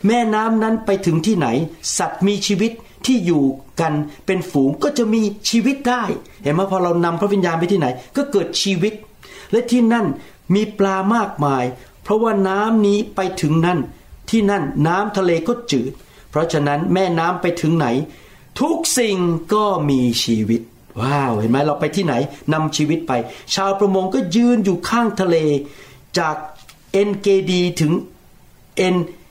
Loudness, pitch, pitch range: -18 LUFS, 185 Hz, 150-210 Hz